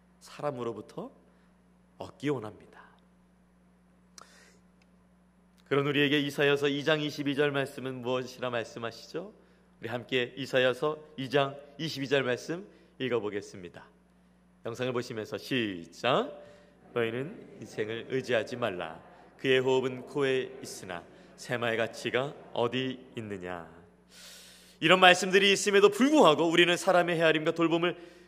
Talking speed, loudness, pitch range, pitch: 265 characters per minute, -28 LUFS, 115-165 Hz, 135 Hz